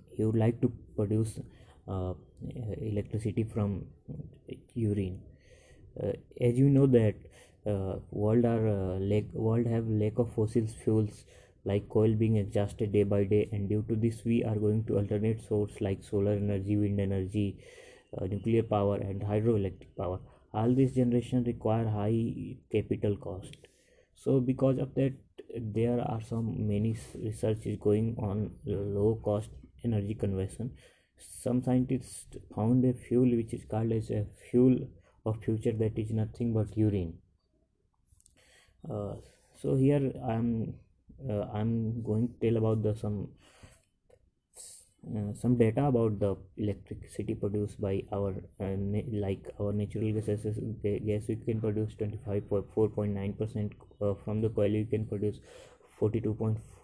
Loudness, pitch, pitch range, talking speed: -31 LUFS, 110 Hz, 105-115 Hz, 150 wpm